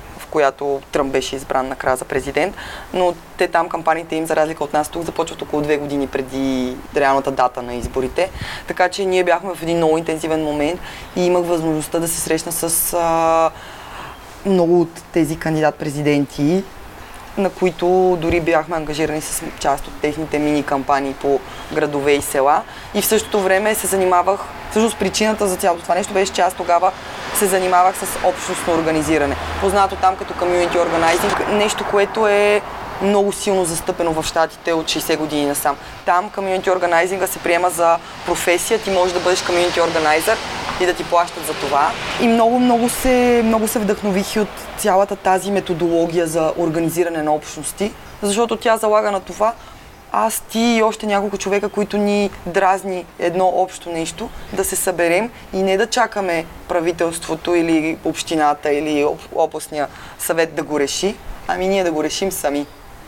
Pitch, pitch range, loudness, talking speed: 175 Hz, 155-195 Hz, -18 LUFS, 165 wpm